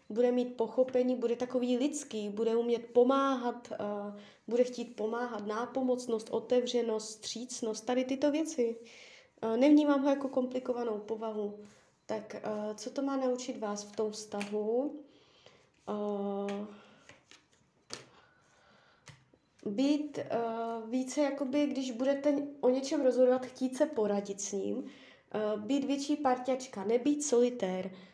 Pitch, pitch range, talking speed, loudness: 245 Hz, 220-270 Hz, 120 wpm, -33 LUFS